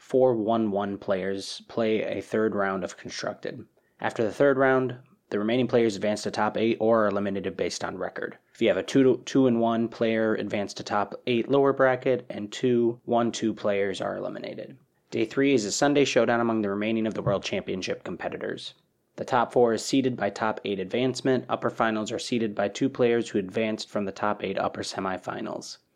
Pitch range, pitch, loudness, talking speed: 105-125 Hz, 115 Hz, -26 LUFS, 195 wpm